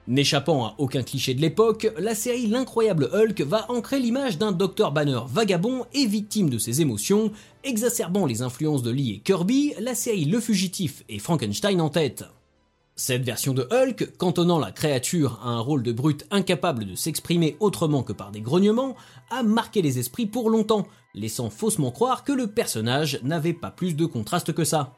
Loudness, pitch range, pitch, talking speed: -24 LUFS, 135-220 Hz, 170 Hz, 185 wpm